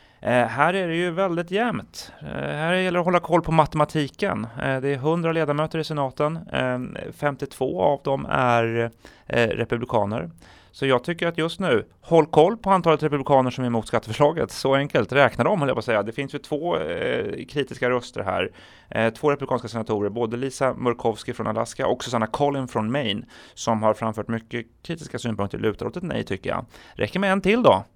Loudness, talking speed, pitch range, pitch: -23 LUFS, 200 wpm, 115-160 Hz, 135 Hz